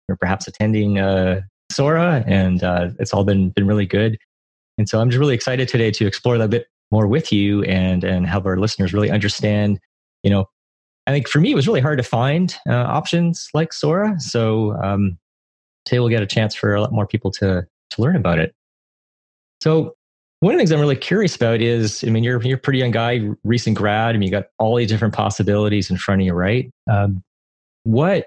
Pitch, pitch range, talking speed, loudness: 105 Hz, 95-125 Hz, 220 wpm, -18 LUFS